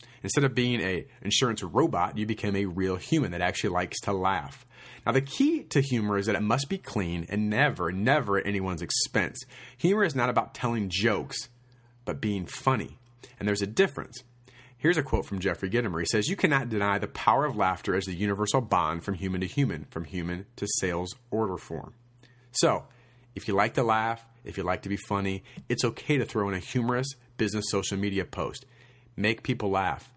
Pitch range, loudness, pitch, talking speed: 100-125 Hz, -28 LUFS, 110 Hz, 200 wpm